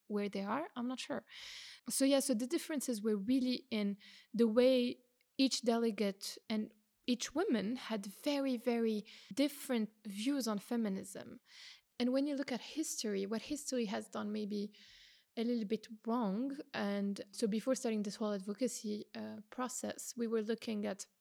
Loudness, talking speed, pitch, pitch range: -38 LUFS, 160 wpm, 230 Hz, 210-255 Hz